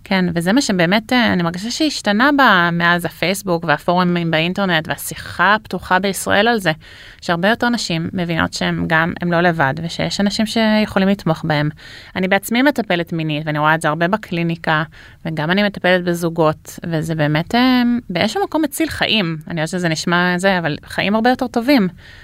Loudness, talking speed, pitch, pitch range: -17 LUFS, 165 wpm, 175 Hz, 160-210 Hz